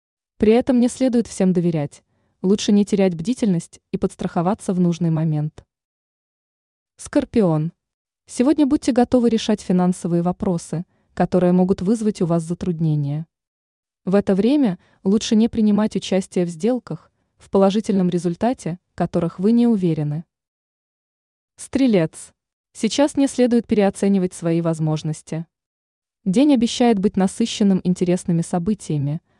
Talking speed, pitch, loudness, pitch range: 115 wpm, 190 Hz, -20 LUFS, 170-225 Hz